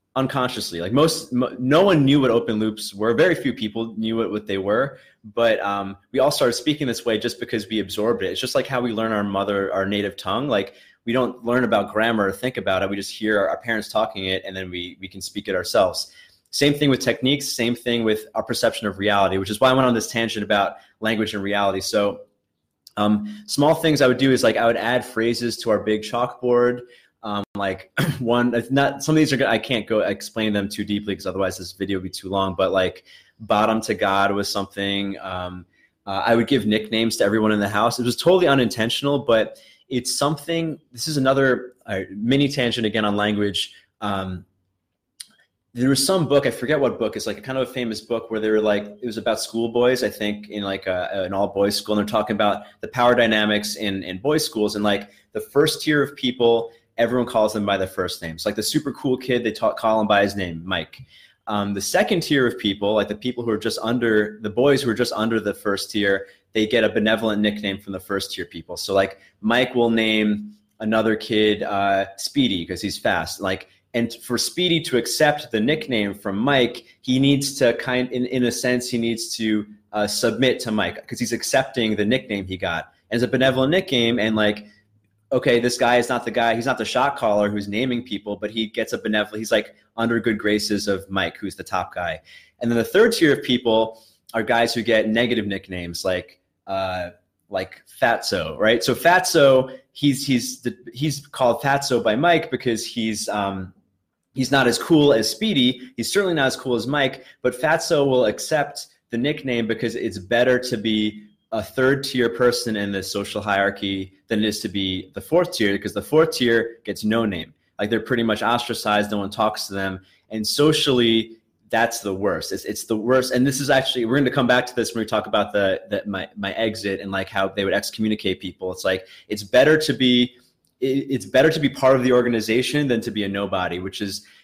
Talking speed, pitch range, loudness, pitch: 225 wpm, 100-125 Hz, -21 LUFS, 110 Hz